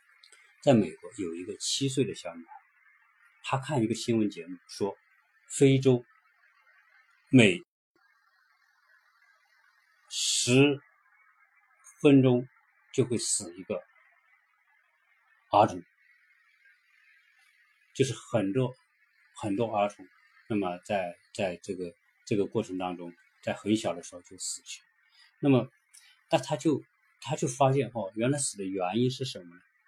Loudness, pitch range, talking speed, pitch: -28 LUFS, 100-140 Hz, 165 characters per minute, 125 Hz